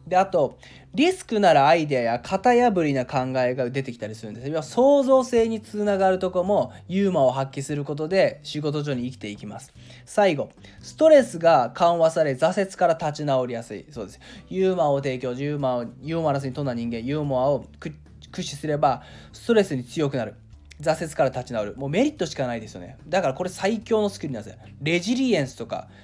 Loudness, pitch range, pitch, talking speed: -23 LUFS, 125-190 Hz, 150 Hz, 415 characters per minute